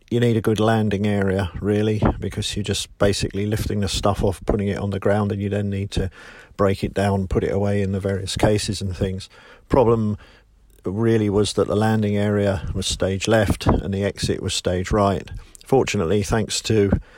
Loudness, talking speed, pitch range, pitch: -21 LUFS, 195 wpm, 100-105 Hz, 100 Hz